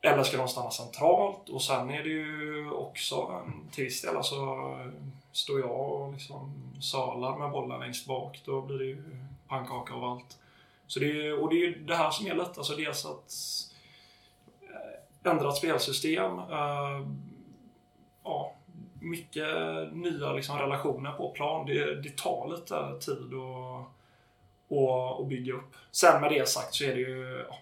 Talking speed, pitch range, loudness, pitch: 155 wpm, 130-150 Hz, -32 LUFS, 135 Hz